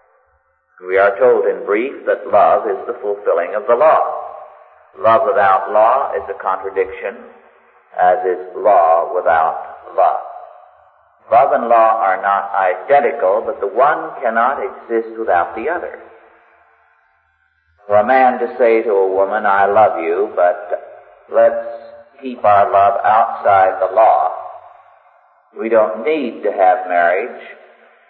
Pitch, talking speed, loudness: 115 Hz, 135 wpm, -15 LUFS